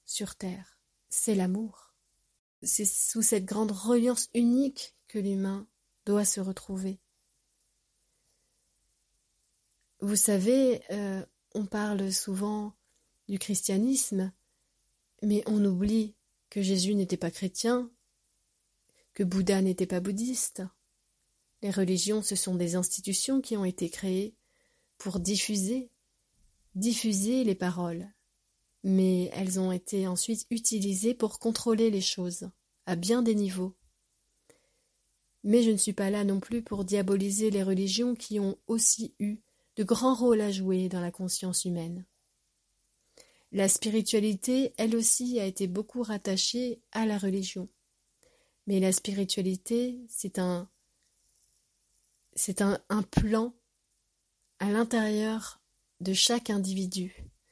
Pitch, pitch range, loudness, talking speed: 205 Hz, 190-225 Hz, -28 LUFS, 120 wpm